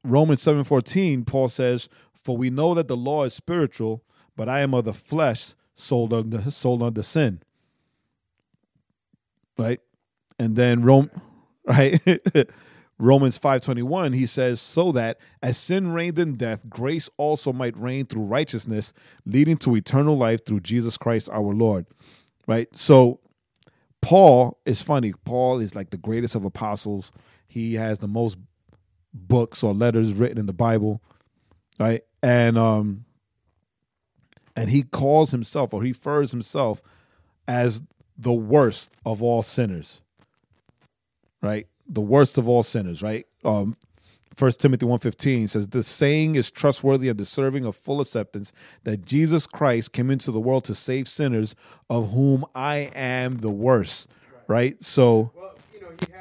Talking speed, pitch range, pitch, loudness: 145 wpm, 110-140 Hz, 120 Hz, -22 LUFS